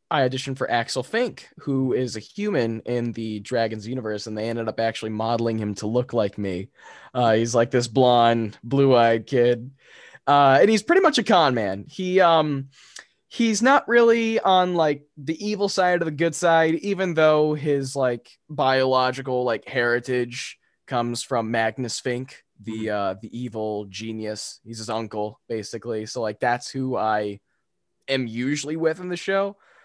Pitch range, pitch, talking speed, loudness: 115-160 Hz, 125 Hz, 170 wpm, -22 LUFS